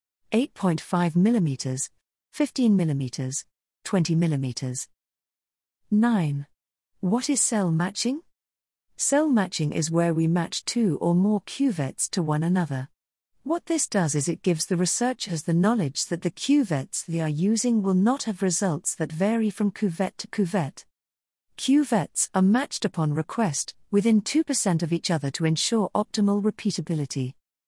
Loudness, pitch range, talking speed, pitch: -25 LUFS, 160-220 Hz, 140 wpm, 185 Hz